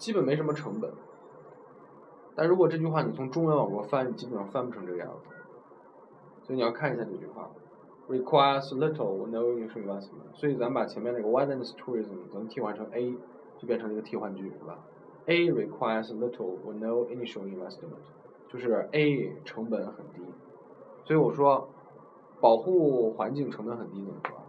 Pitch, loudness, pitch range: 130 Hz, -30 LUFS, 115-155 Hz